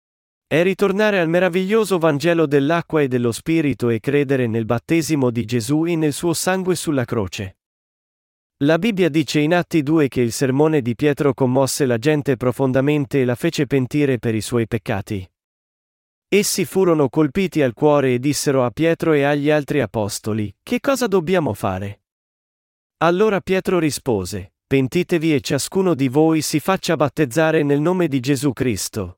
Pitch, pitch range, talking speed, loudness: 145 Hz, 125-165 Hz, 160 wpm, -19 LUFS